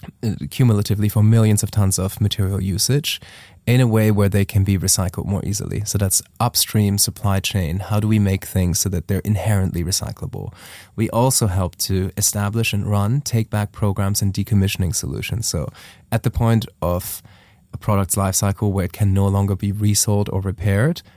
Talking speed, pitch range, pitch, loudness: 180 wpm, 95-110 Hz, 100 Hz, -19 LUFS